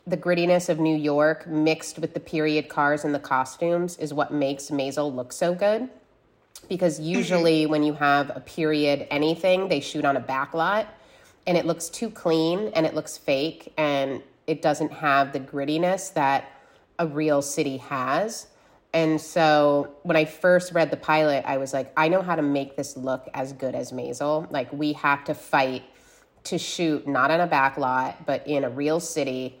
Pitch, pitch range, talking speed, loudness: 155 Hz, 140-165 Hz, 190 wpm, -24 LUFS